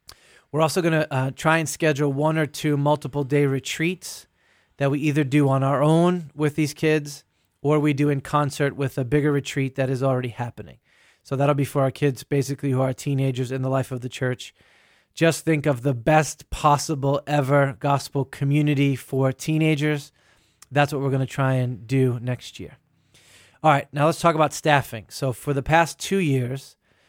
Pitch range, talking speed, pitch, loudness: 135-150 Hz, 195 wpm, 145 Hz, -22 LUFS